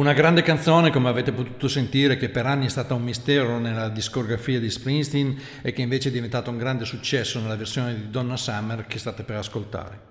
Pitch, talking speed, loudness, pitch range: 125 Hz, 210 wpm, -24 LUFS, 115-135 Hz